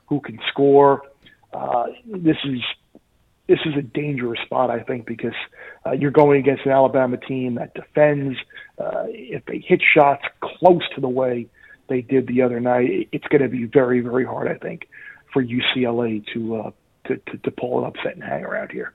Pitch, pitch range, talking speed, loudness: 130 Hz, 125-145 Hz, 190 wpm, -20 LUFS